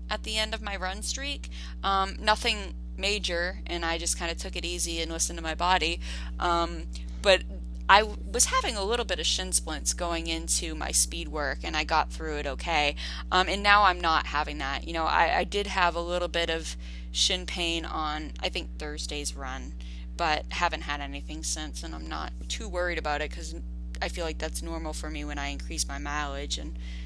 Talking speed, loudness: 210 wpm, -28 LUFS